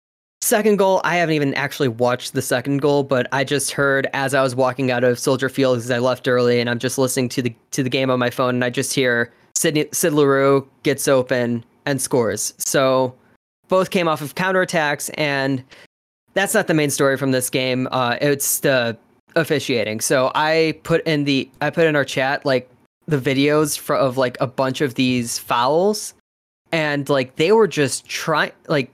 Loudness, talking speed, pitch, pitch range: -19 LUFS, 200 wpm, 135 Hz, 130-150 Hz